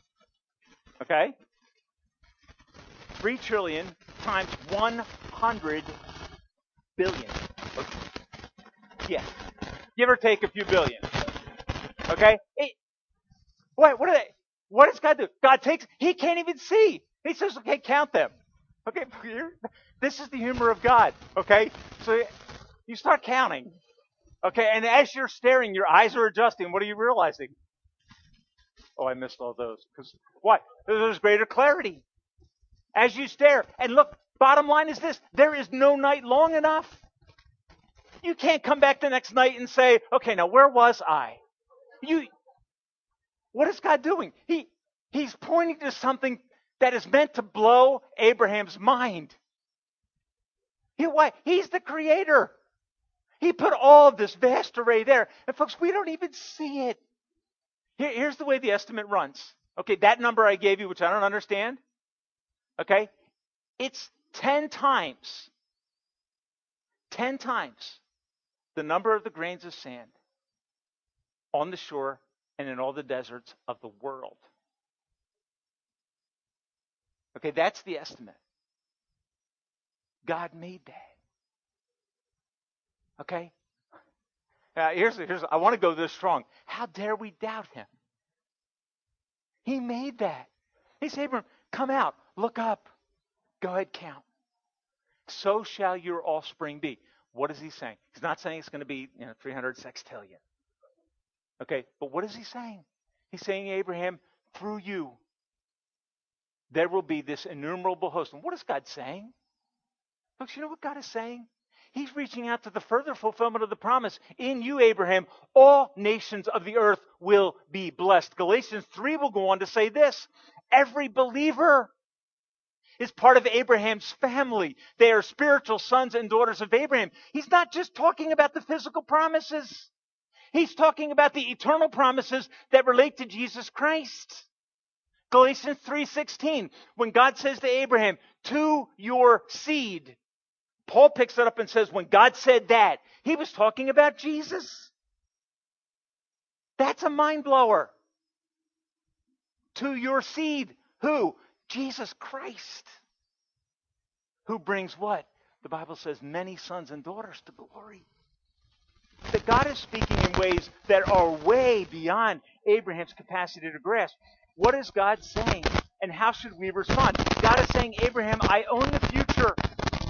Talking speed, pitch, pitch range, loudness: 140 wpm, 240 Hz, 200-285 Hz, -24 LUFS